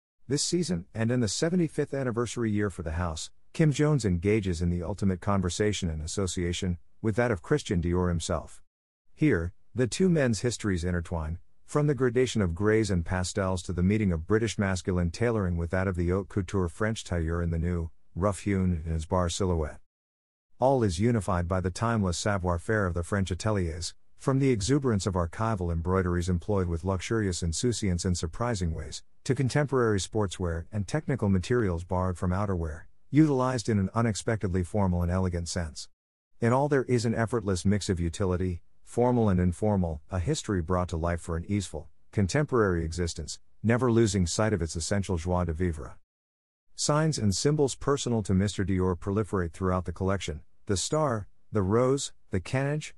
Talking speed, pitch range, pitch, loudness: 175 wpm, 90-115 Hz, 95 Hz, -28 LUFS